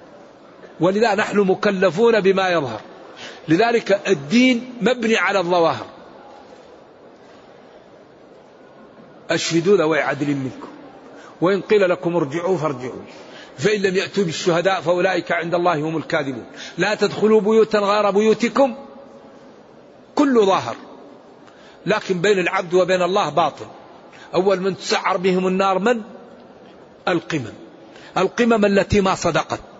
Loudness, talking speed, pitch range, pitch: -19 LUFS, 105 wpm, 170-210 Hz, 190 Hz